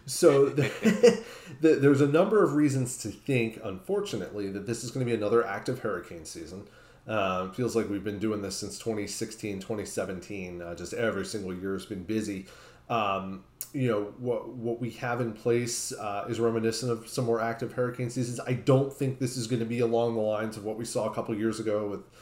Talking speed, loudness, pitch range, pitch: 210 wpm, -29 LUFS, 105-125 Hz, 115 Hz